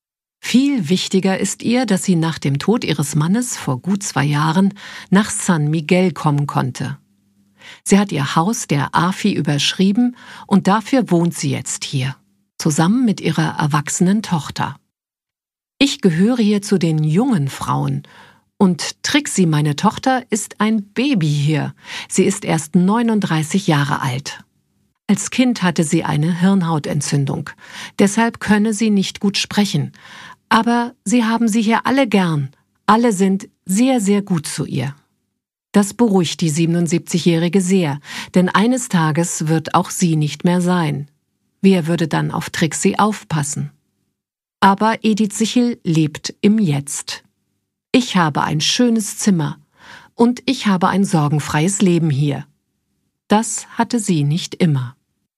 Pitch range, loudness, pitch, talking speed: 155-215 Hz, -17 LUFS, 185 Hz, 140 wpm